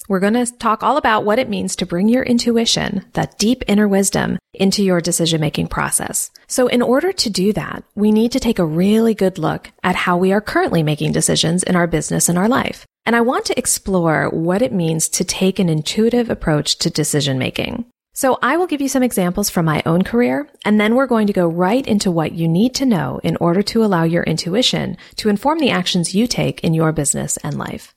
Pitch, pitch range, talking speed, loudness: 200 Hz, 175-235 Hz, 225 wpm, -17 LUFS